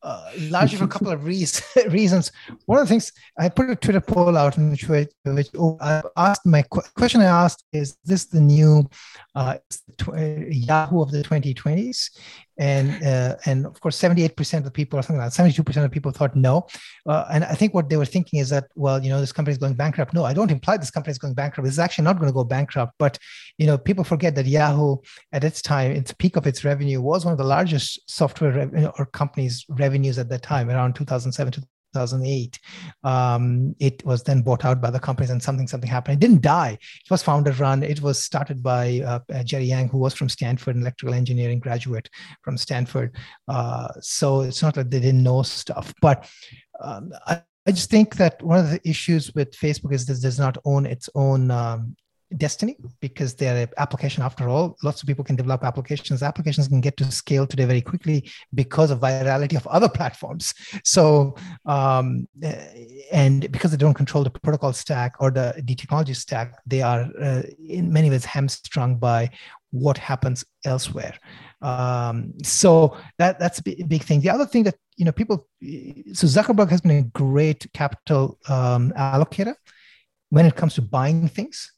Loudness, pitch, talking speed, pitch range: -21 LUFS, 145 Hz, 200 wpm, 130-160 Hz